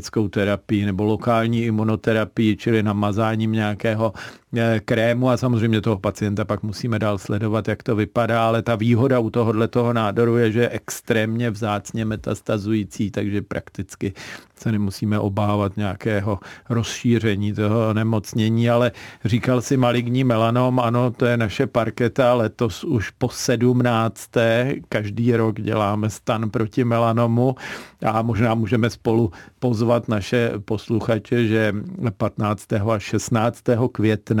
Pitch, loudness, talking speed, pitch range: 115 Hz, -21 LUFS, 125 wpm, 105-120 Hz